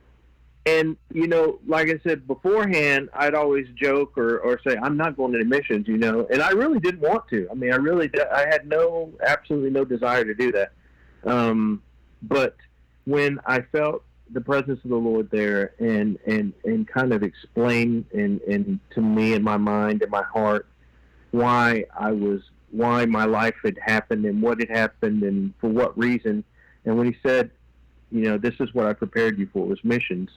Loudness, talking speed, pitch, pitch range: -23 LUFS, 195 wpm, 120 Hz, 110-160 Hz